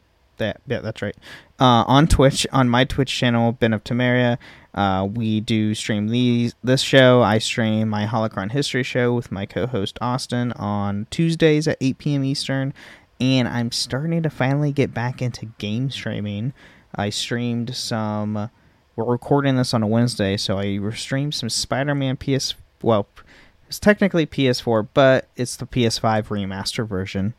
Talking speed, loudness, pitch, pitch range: 160 wpm, -21 LUFS, 120 Hz, 105-130 Hz